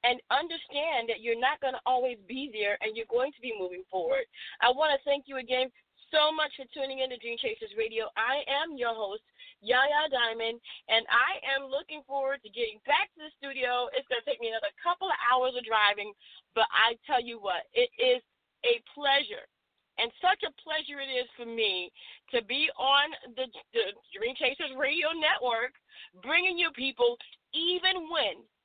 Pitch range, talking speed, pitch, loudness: 235-310 Hz, 190 wpm, 270 Hz, -29 LUFS